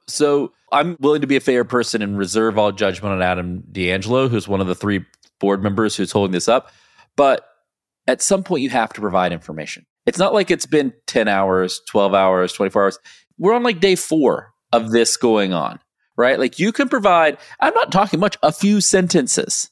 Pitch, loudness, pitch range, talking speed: 115 Hz, -18 LUFS, 100-155 Hz, 205 wpm